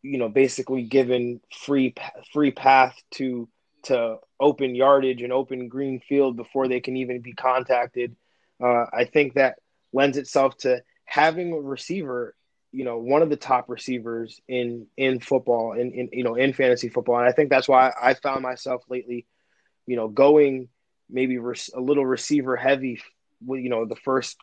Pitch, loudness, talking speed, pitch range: 130 Hz, -23 LUFS, 180 wpm, 120-135 Hz